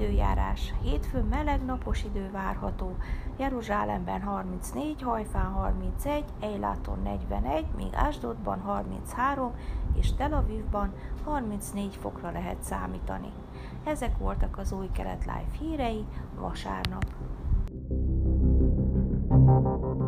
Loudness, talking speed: -31 LUFS, 90 wpm